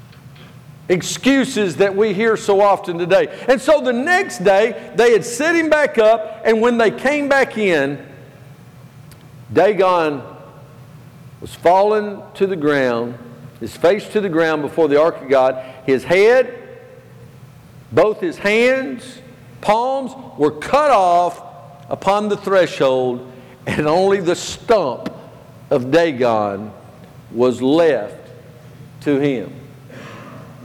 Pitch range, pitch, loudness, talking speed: 135-215 Hz, 160 Hz, -16 LUFS, 120 wpm